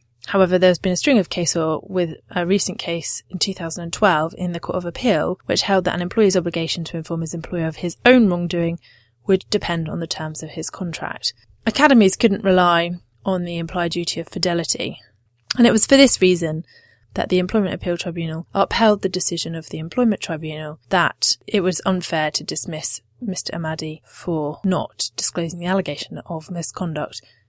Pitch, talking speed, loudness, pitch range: 175 Hz, 190 wpm, -20 LUFS, 160-190 Hz